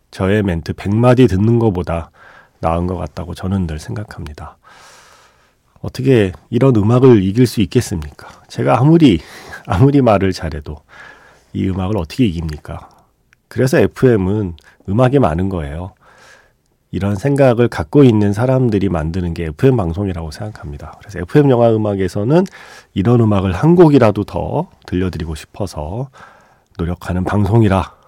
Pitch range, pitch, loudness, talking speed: 85-120 Hz, 100 Hz, -15 LUFS, 315 characters per minute